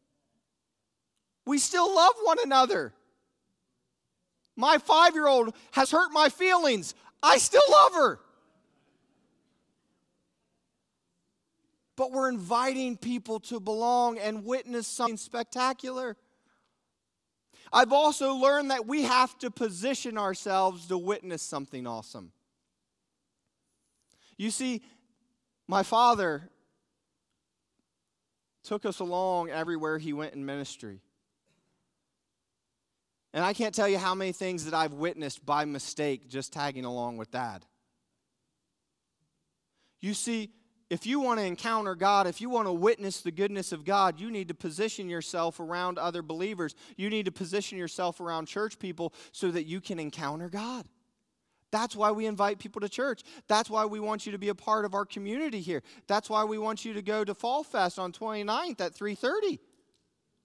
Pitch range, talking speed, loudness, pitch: 180-245 Hz, 140 wpm, -28 LUFS, 215 Hz